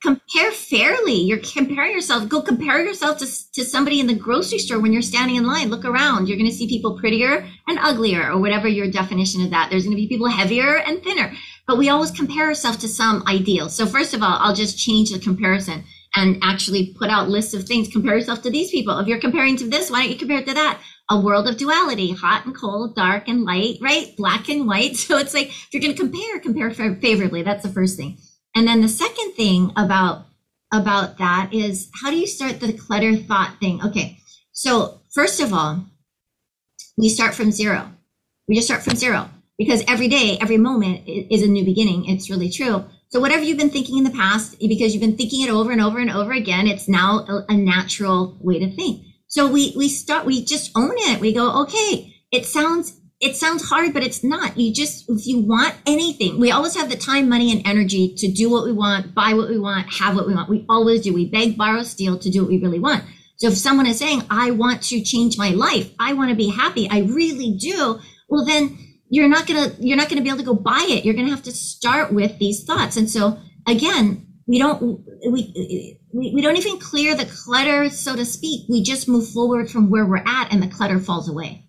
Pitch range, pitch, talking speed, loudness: 200-270 Hz, 225 Hz, 230 wpm, -19 LUFS